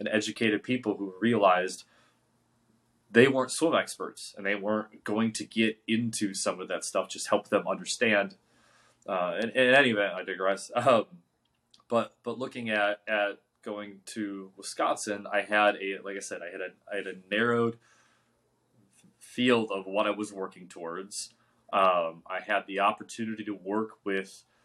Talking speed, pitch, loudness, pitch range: 160 wpm, 105 Hz, -29 LUFS, 100-115 Hz